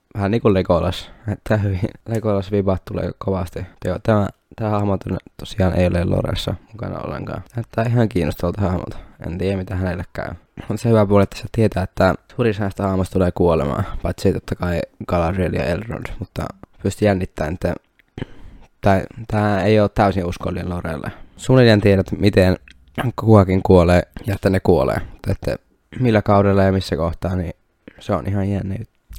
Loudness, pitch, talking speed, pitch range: -19 LUFS, 95 Hz, 160 wpm, 90-105 Hz